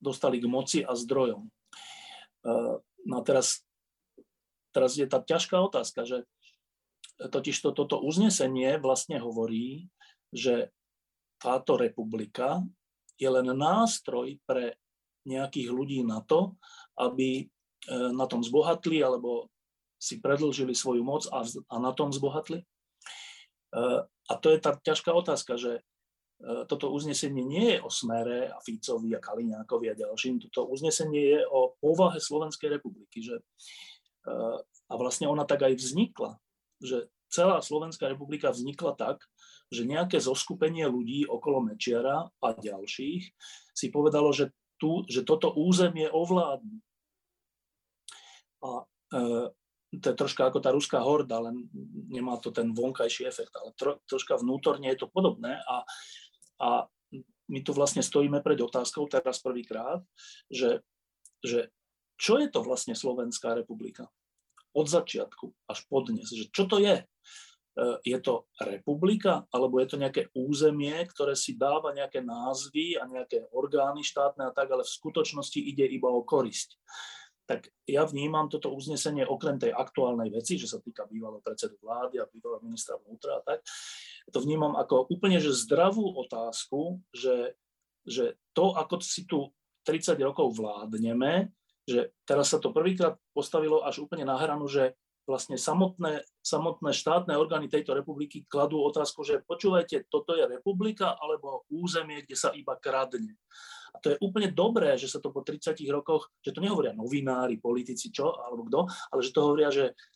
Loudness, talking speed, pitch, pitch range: -30 LUFS, 145 wpm, 150 Hz, 130-215 Hz